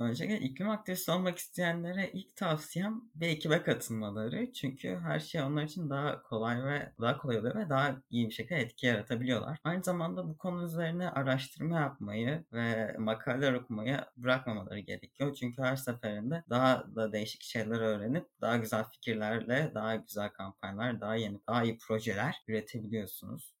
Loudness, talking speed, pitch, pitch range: -35 LUFS, 155 wpm, 130 Hz, 110-160 Hz